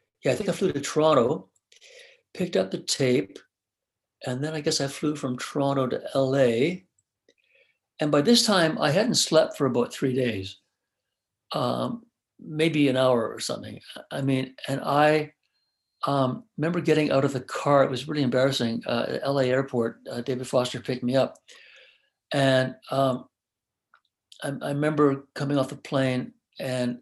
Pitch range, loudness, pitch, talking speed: 130-155 Hz, -25 LUFS, 135 Hz, 160 wpm